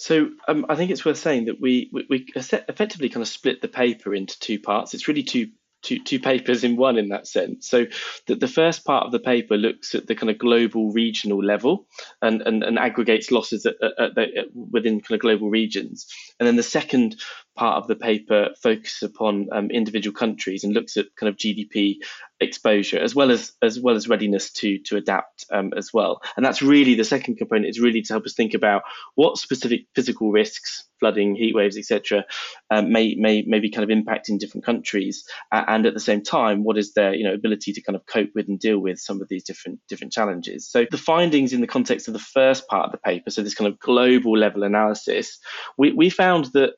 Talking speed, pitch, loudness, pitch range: 225 wpm, 110 Hz, -21 LUFS, 105-125 Hz